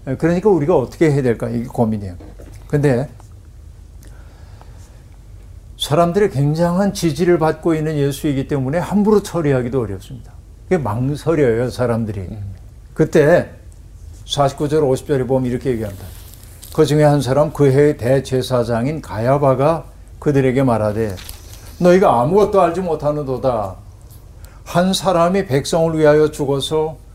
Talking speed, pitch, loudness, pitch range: 295 characters per minute, 130 Hz, -16 LUFS, 105-155 Hz